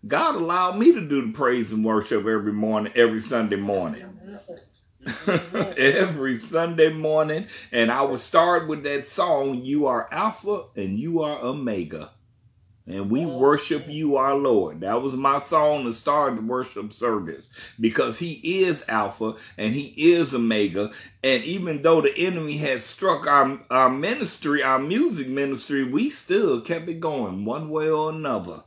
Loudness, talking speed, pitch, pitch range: -23 LUFS, 160 wpm, 140 Hz, 115-165 Hz